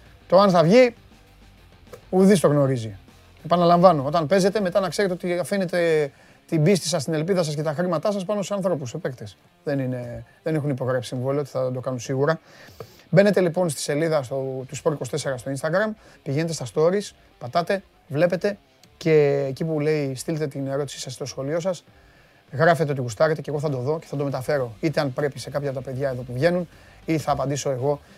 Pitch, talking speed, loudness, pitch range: 150 Hz, 195 wpm, -23 LUFS, 135-175 Hz